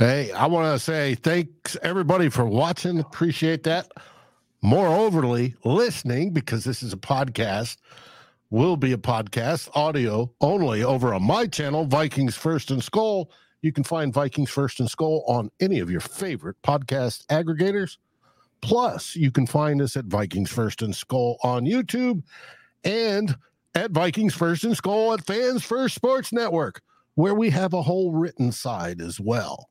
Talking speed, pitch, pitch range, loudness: 160 wpm, 150 Hz, 125-180 Hz, -24 LUFS